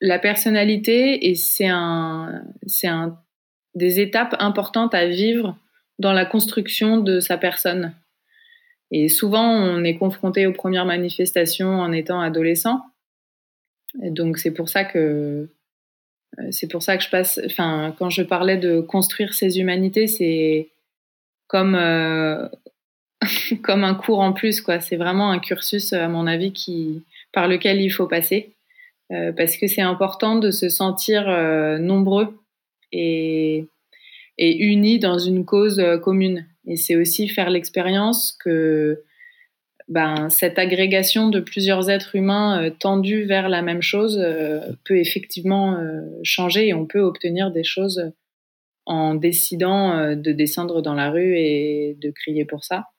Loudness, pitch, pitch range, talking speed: -19 LUFS, 185 Hz, 165-200 Hz, 150 wpm